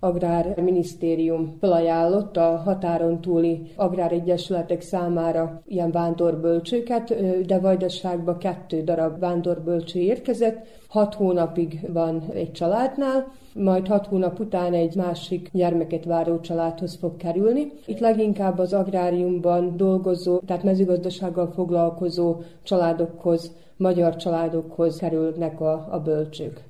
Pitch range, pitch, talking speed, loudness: 165-185 Hz, 175 Hz, 105 wpm, -23 LUFS